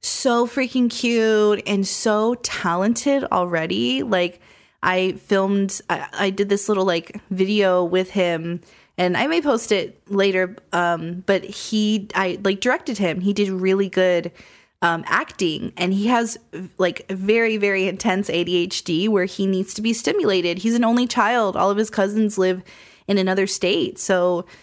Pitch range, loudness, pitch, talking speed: 180-215 Hz, -20 LUFS, 195 Hz, 160 wpm